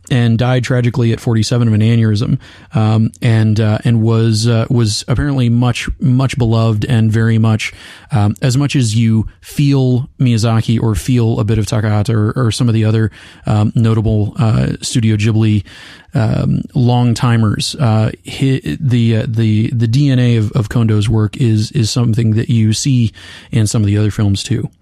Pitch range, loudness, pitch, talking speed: 110-125 Hz, -14 LUFS, 115 Hz, 175 wpm